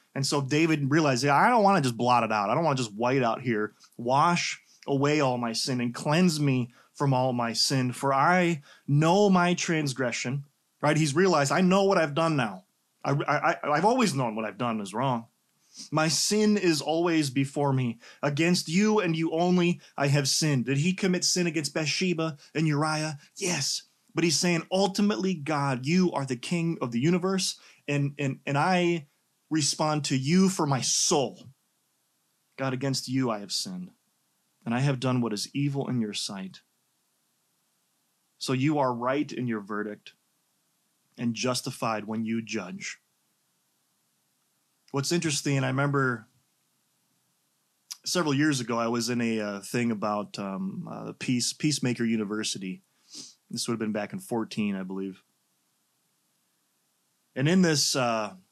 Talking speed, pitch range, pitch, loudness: 165 wpm, 125-170 Hz, 140 Hz, -26 LUFS